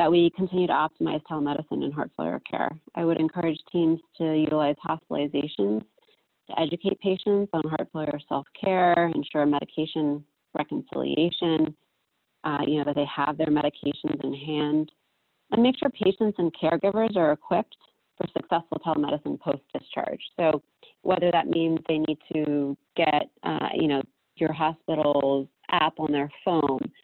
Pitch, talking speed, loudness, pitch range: 155 Hz, 145 wpm, -26 LUFS, 150-170 Hz